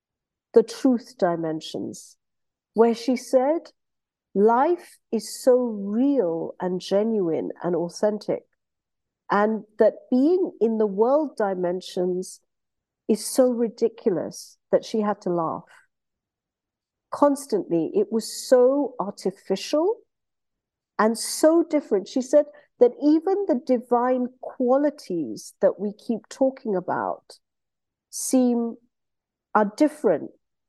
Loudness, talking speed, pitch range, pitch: -23 LUFS, 100 wpm, 200-280 Hz, 230 Hz